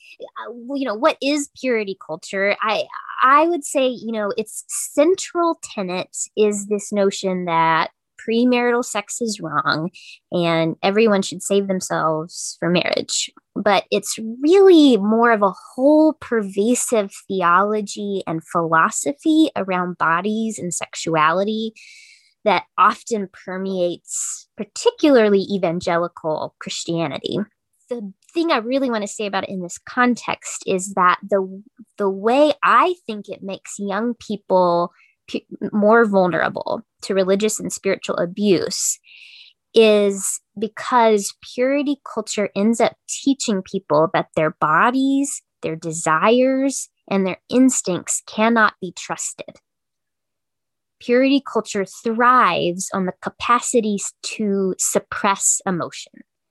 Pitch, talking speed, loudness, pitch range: 210 Hz, 115 wpm, -19 LUFS, 190-245 Hz